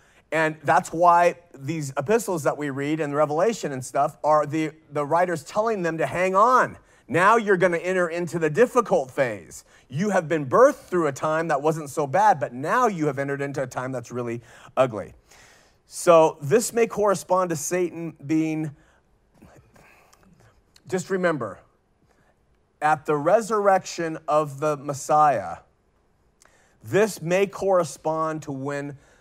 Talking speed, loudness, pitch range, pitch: 145 wpm, -23 LUFS, 145-185 Hz, 160 Hz